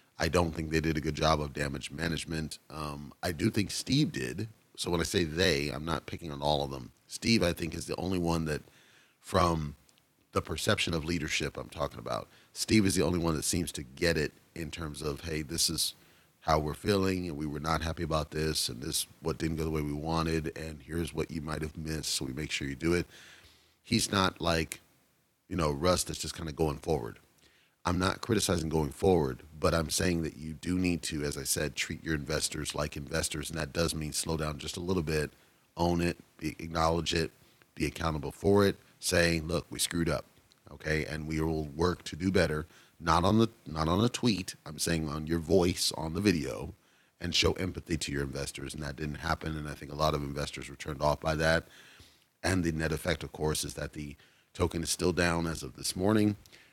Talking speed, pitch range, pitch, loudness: 225 wpm, 75-85 Hz, 80 Hz, -31 LUFS